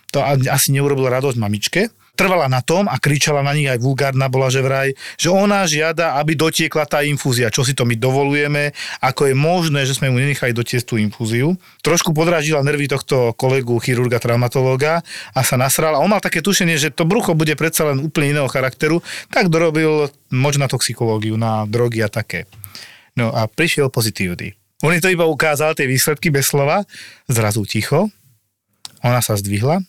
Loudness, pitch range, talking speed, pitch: -17 LUFS, 125-155 Hz, 175 wpm, 140 Hz